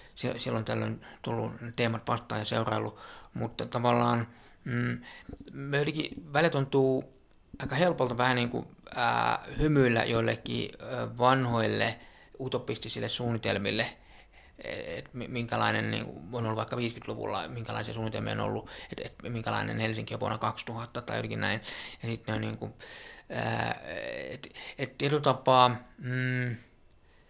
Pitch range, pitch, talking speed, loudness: 110-125 Hz, 120 Hz, 125 wpm, -31 LUFS